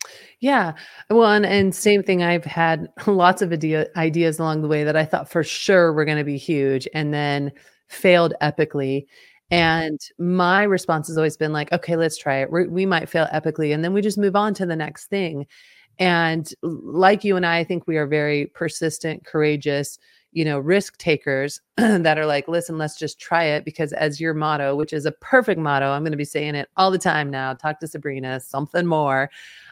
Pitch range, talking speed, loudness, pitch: 150-180 Hz, 210 wpm, -21 LUFS, 160 Hz